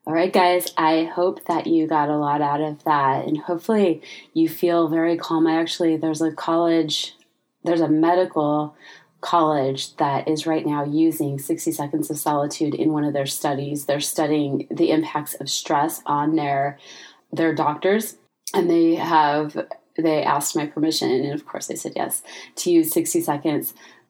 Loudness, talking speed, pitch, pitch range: -21 LUFS, 170 wpm, 160 Hz, 150-170 Hz